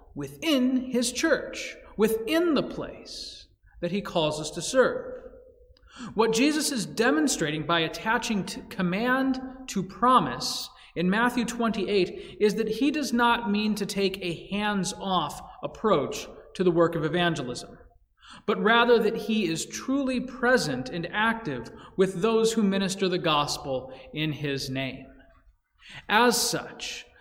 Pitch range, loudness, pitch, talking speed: 170-245 Hz, -26 LUFS, 210 Hz, 135 wpm